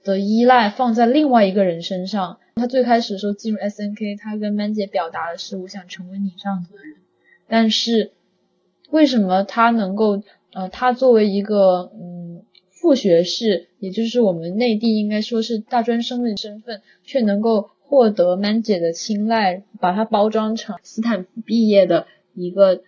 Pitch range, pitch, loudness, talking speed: 190-230 Hz, 210 Hz, -18 LUFS, 275 characters per minute